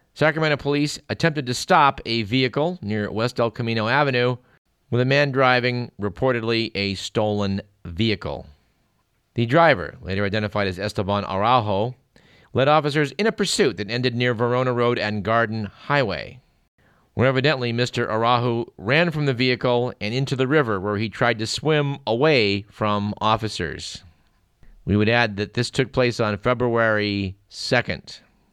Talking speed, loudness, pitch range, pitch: 145 wpm, -21 LUFS, 105-130 Hz, 120 Hz